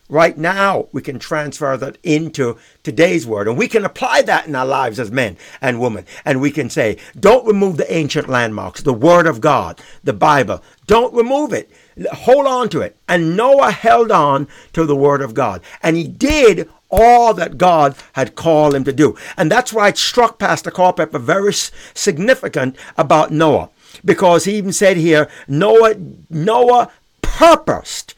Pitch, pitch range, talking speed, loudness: 165 Hz, 145-215 Hz, 175 wpm, -14 LUFS